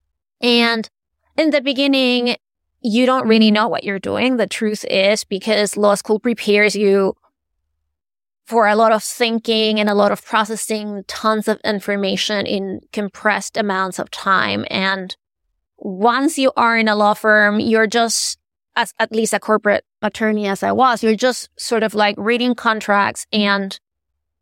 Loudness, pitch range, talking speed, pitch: -17 LUFS, 200-230 Hz, 155 wpm, 215 Hz